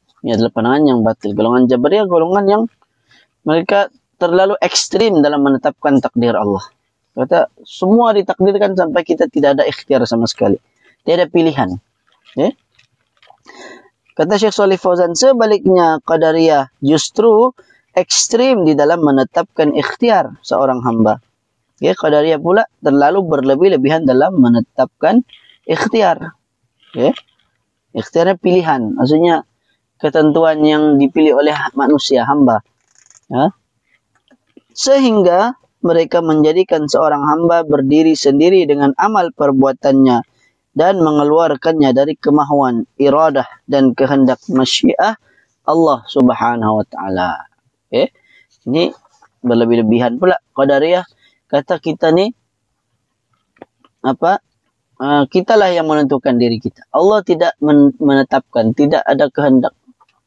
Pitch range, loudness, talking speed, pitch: 130-180 Hz, -13 LUFS, 105 wpm, 150 Hz